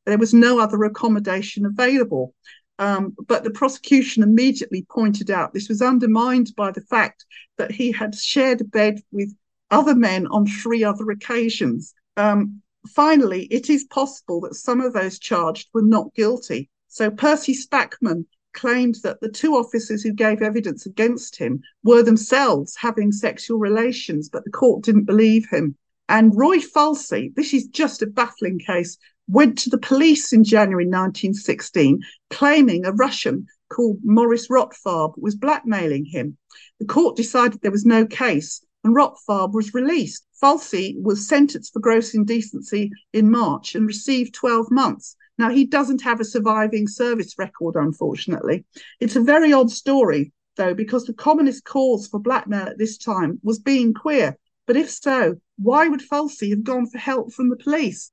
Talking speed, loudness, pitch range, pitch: 160 wpm, -19 LUFS, 210-260 Hz, 230 Hz